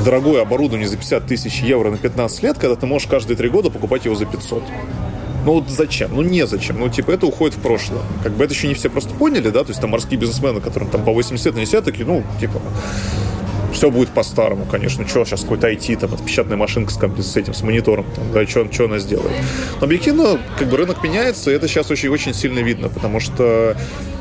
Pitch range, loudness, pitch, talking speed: 105-140 Hz, -18 LUFS, 115 Hz, 220 wpm